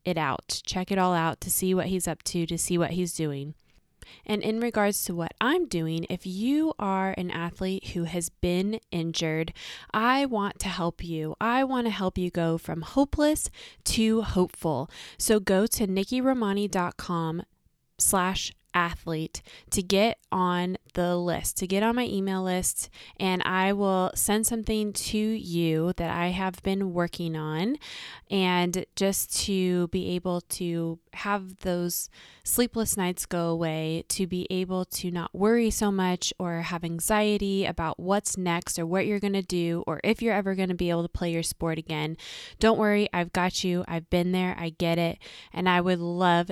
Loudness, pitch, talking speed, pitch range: -27 LUFS, 185 Hz, 180 wpm, 170-200 Hz